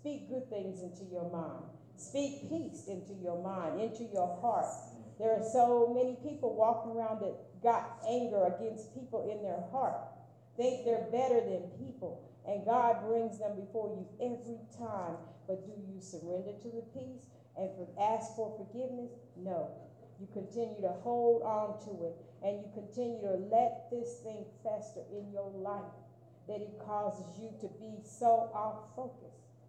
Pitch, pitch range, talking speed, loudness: 215 Hz, 195-235 Hz, 165 wpm, -36 LUFS